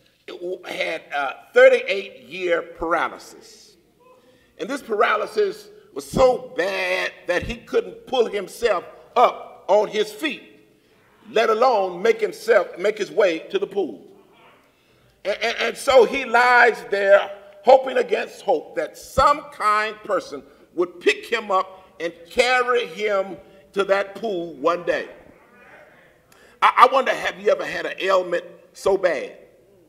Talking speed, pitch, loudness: 135 wpm, 250 Hz, -21 LUFS